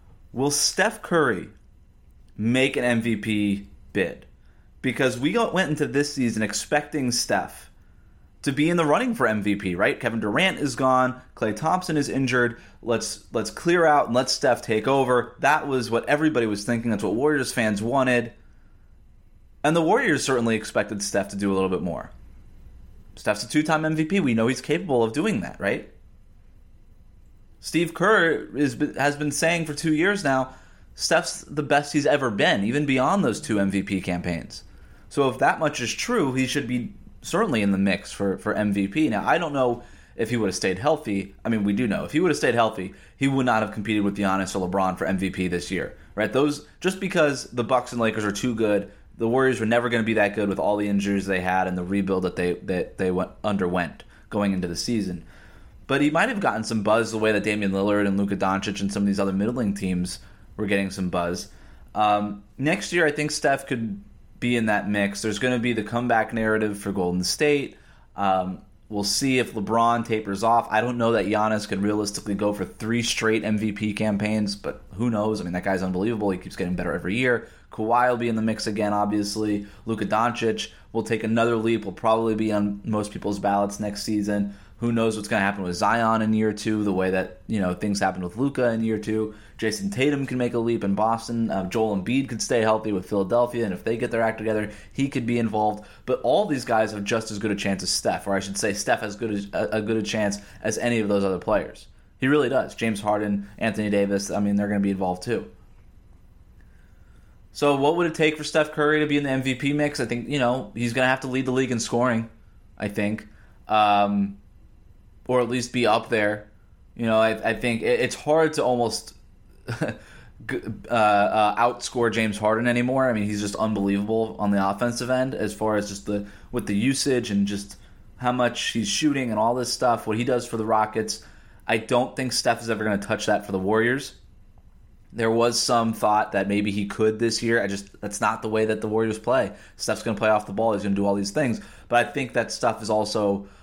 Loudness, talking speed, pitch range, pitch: -24 LUFS, 220 wpm, 100-125 Hz, 110 Hz